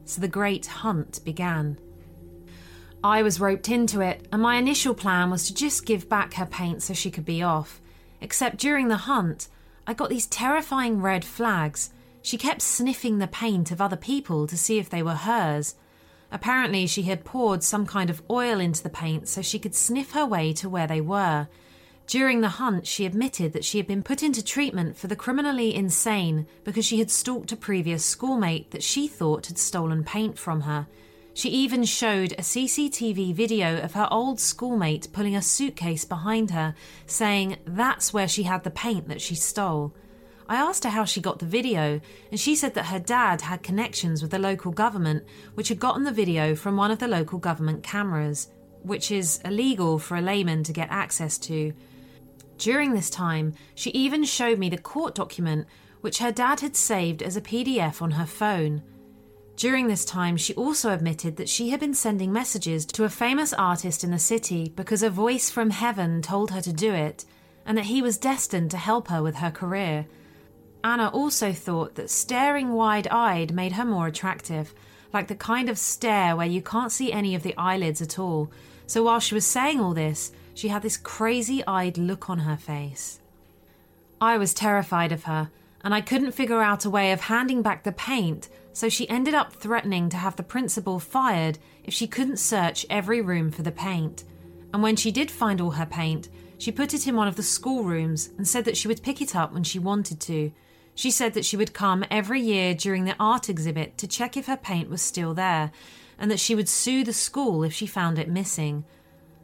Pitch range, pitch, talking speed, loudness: 165-230 Hz, 195 Hz, 200 wpm, -25 LUFS